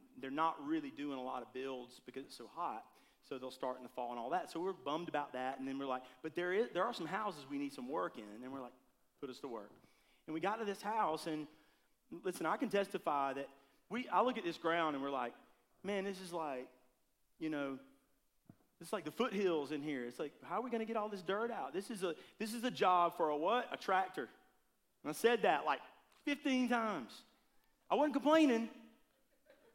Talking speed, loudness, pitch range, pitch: 235 wpm, -39 LUFS, 135-220 Hz, 170 Hz